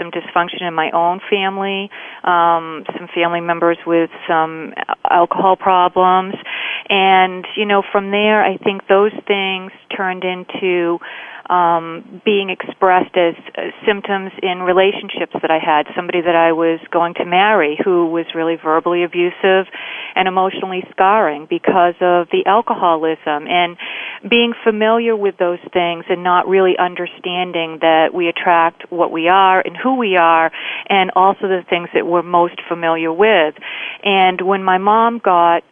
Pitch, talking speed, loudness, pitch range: 180 Hz, 150 wpm, -15 LUFS, 170-195 Hz